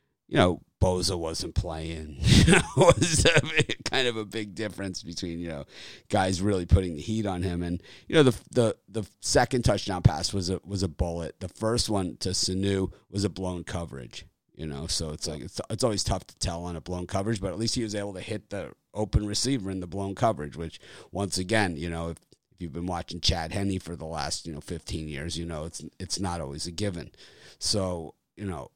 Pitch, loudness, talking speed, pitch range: 95 Hz, -28 LUFS, 220 wpm, 85-105 Hz